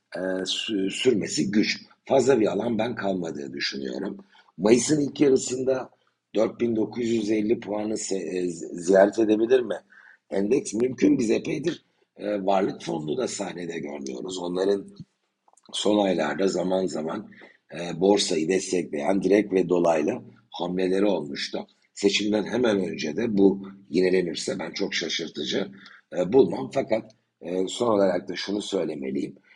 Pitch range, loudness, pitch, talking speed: 90-105 Hz, -25 LUFS, 95 Hz, 110 wpm